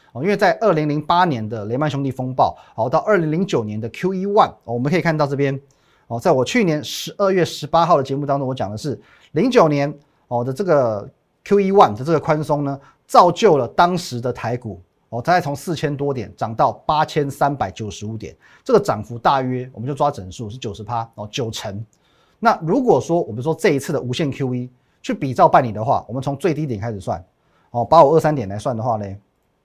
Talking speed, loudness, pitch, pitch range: 325 characters per minute, -19 LUFS, 140 Hz, 120-160 Hz